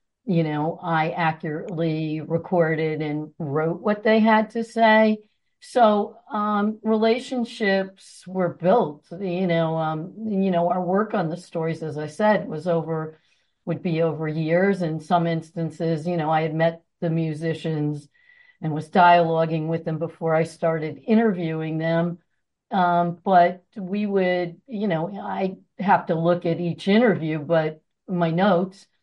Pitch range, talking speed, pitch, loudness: 160-195 Hz, 150 wpm, 170 Hz, -23 LUFS